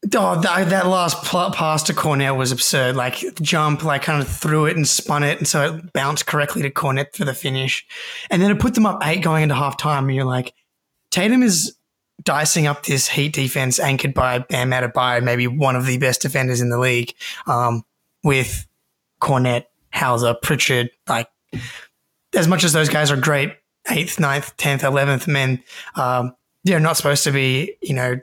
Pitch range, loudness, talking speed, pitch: 125-160 Hz, -18 LUFS, 190 wpm, 140 Hz